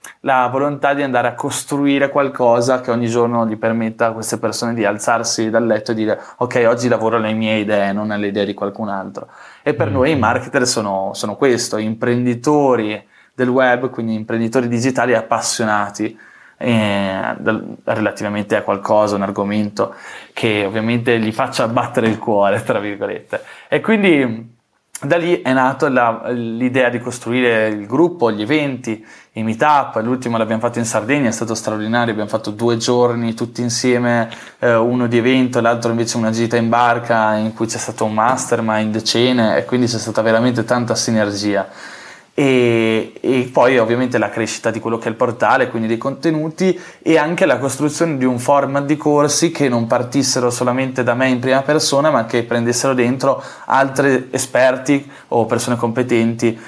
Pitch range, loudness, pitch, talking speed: 110-130 Hz, -16 LUFS, 120 Hz, 170 wpm